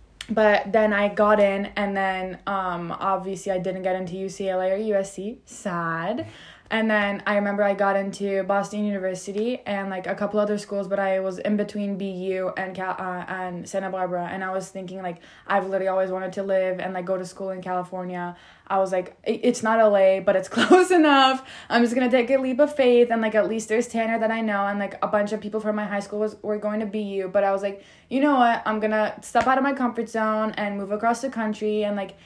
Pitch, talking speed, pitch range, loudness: 200 Hz, 240 wpm, 190-215 Hz, -23 LUFS